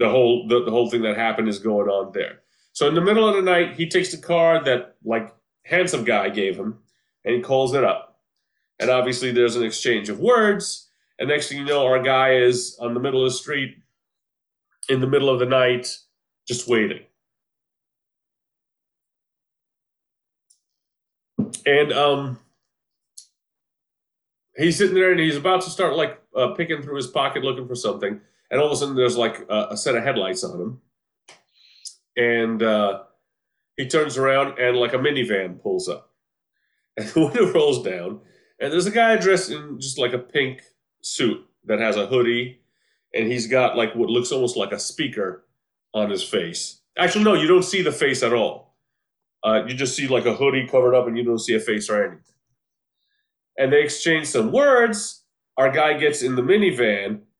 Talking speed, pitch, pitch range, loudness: 185 wpm, 135 Hz, 125-180 Hz, -21 LUFS